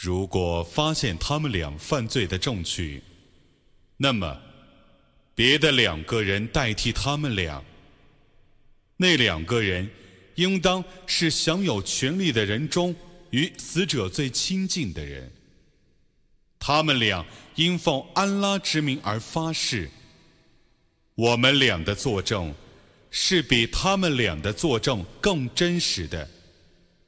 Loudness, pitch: -23 LUFS, 130 Hz